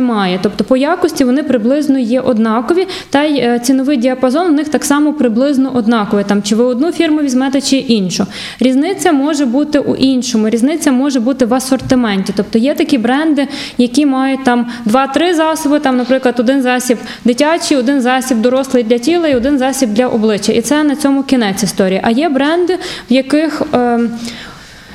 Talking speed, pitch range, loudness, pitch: 170 wpm, 240-285 Hz, -12 LUFS, 265 Hz